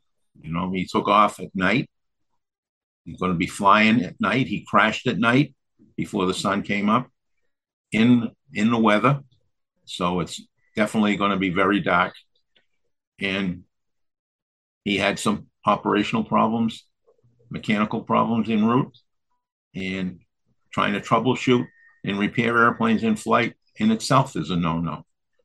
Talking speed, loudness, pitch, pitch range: 140 wpm, -22 LUFS, 115 Hz, 95-130 Hz